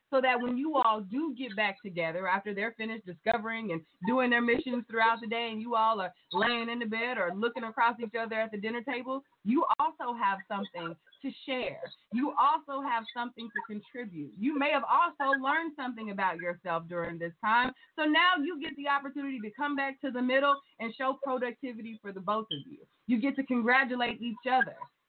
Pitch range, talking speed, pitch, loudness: 220-270 Hz, 205 wpm, 235 Hz, -31 LUFS